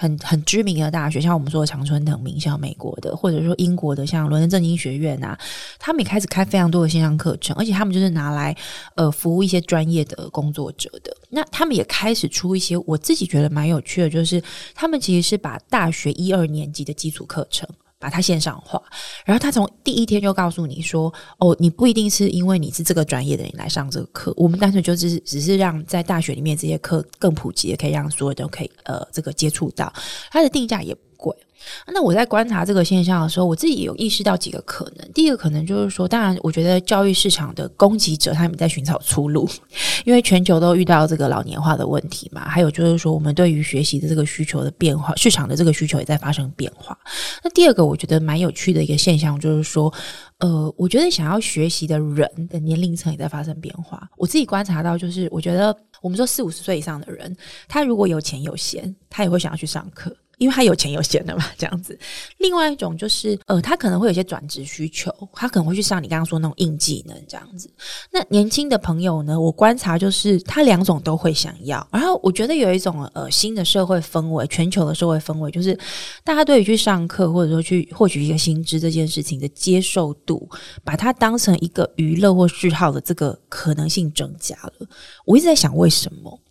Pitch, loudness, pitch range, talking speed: 170 Hz, -19 LUFS, 155-195 Hz, 345 characters per minute